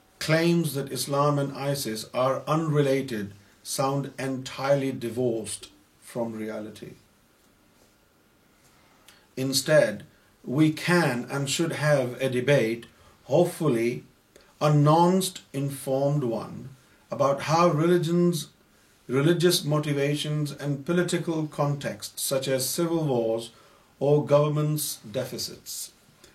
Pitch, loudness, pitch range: 140 Hz, -25 LUFS, 130-155 Hz